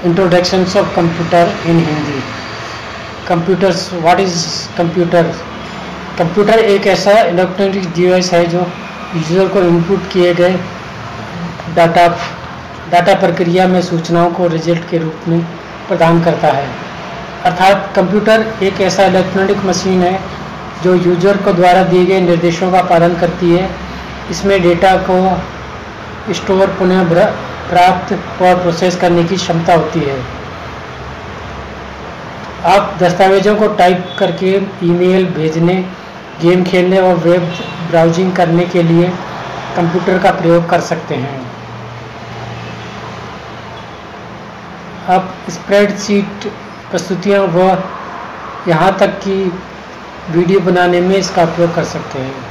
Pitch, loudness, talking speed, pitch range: 180 Hz, -12 LUFS, 115 wpm, 170-190 Hz